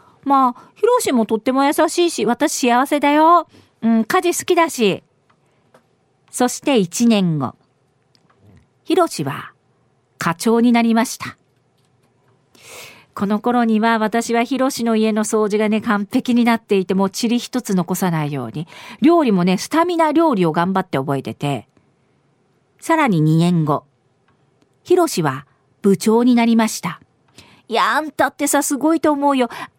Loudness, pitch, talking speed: -17 LUFS, 225 Hz, 265 characters per minute